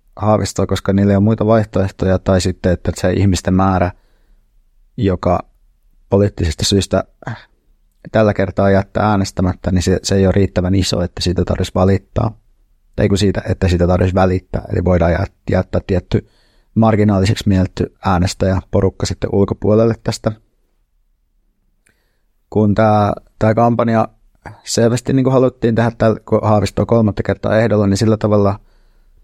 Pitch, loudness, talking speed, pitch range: 100 Hz, -15 LUFS, 130 wpm, 95-110 Hz